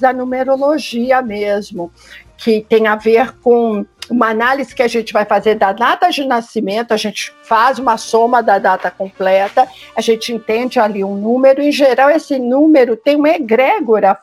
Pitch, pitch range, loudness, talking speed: 230 Hz, 215-260 Hz, -13 LUFS, 170 wpm